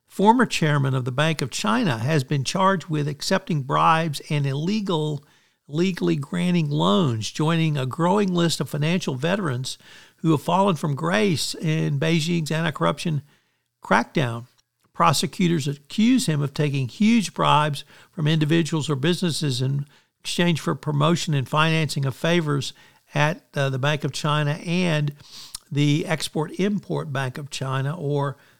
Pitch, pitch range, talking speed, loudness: 155 Hz, 145-170 Hz, 140 wpm, -23 LUFS